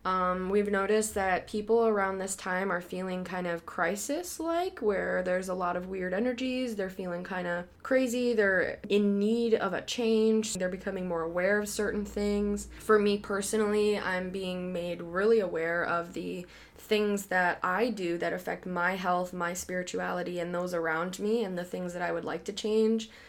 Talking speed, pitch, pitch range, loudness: 185 wpm, 190 Hz, 180-215 Hz, -30 LUFS